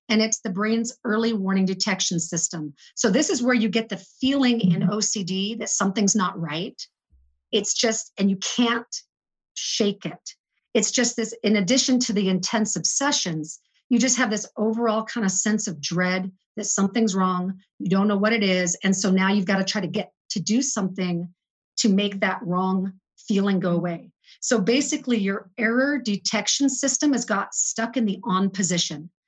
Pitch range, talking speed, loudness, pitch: 185-230 Hz, 180 wpm, -23 LUFS, 205 Hz